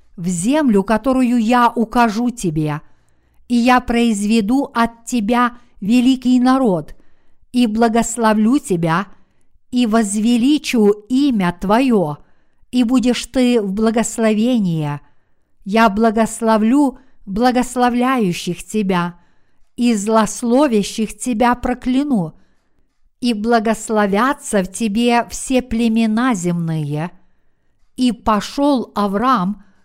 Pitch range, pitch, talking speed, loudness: 205-245 Hz, 230 Hz, 85 wpm, -16 LUFS